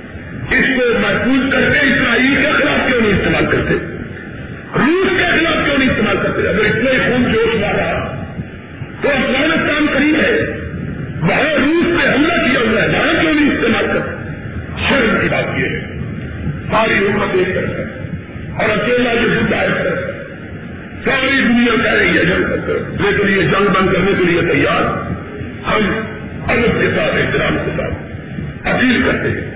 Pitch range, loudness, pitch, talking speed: 200-280 Hz, -14 LUFS, 240 Hz, 155 wpm